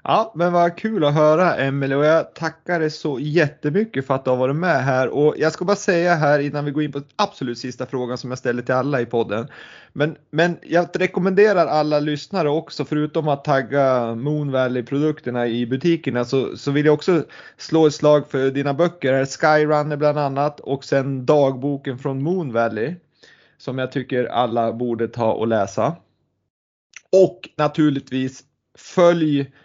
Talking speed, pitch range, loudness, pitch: 175 wpm, 130-160 Hz, -20 LUFS, 145 Hz